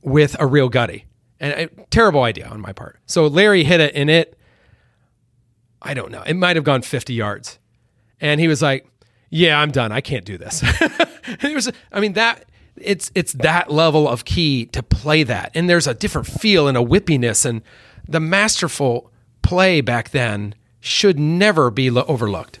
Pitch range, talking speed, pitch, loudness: 120-165 Hz, 190 wpm, 140 Hz, -17 LUFS